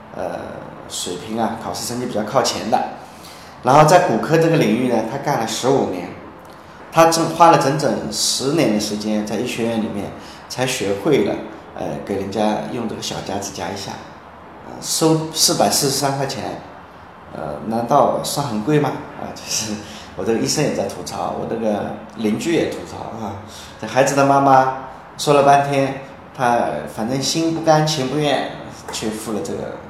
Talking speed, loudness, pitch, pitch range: 250 characters per minute, -18 LUFS, 115 Hz, 100-140 Hz